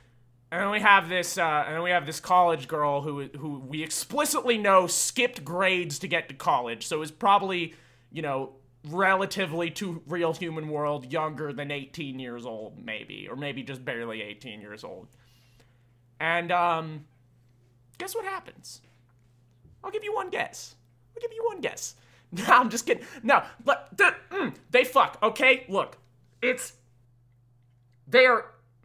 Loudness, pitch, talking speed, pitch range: -26 LUFS, 155 Hz, 155 wpm, 120-190 Hz